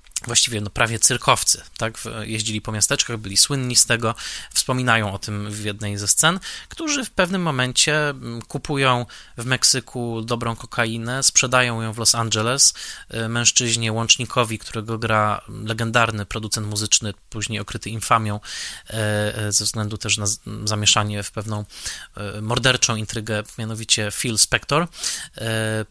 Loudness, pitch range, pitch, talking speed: -20 LUFS, 105-120 Hz, 115 Hz, 125 wpm